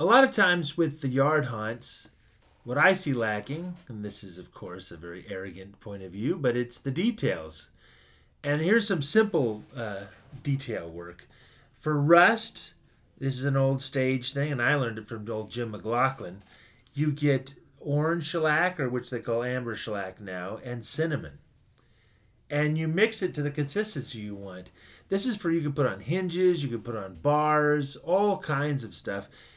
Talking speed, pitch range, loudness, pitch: 180 wpm, 110-155 Hz, -28 LUFS, 135 Hz